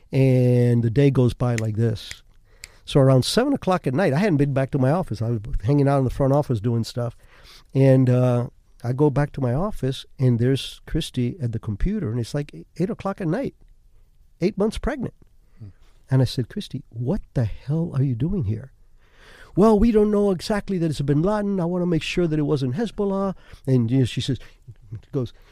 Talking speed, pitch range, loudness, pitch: 215 wpm, 115-160 Hz, -22 LUFS, 130 Hz